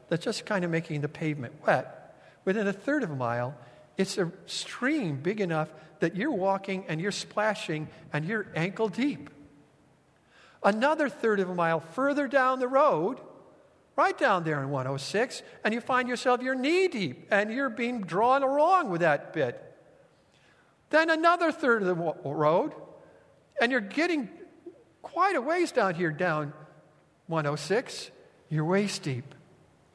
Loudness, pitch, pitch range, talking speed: -28 LUFS, 200 Hz, 160-270 Hz, 155 wpm